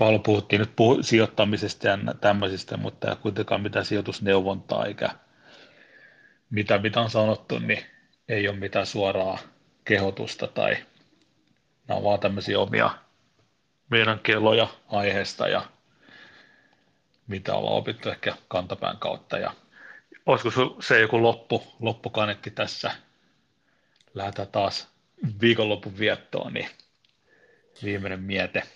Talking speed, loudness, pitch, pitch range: 105 wpm, -25 LUFS, 105 Hz, 100-110 Hz